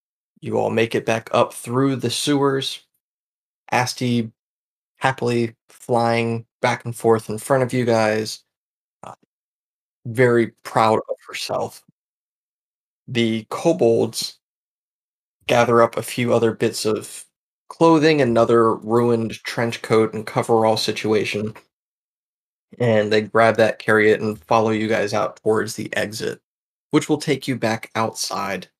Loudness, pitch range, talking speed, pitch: -20 LUFS, 110-125 Hz, 130 wpm, 115 Hz